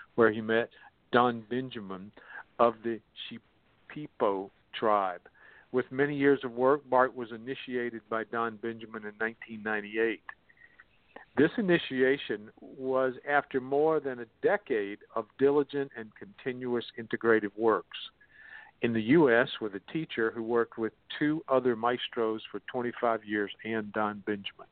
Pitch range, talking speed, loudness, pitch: 110-130 Hz, 130 wpm, -30 LUFS, 115 Hz